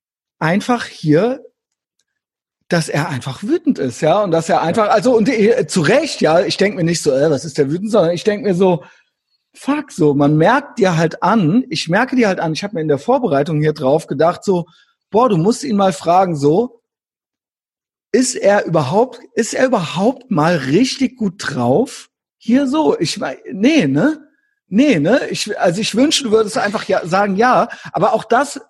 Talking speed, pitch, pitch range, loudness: 195 wpm, 200 Hz, 165-250 Hz, -15 LUFS